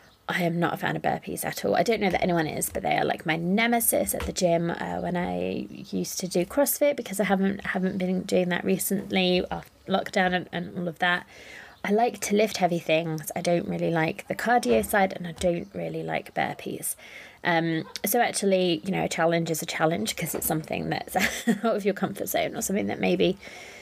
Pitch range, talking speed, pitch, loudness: 165-200 Hz, 220 wpm, 180 Hz, -26 LUFS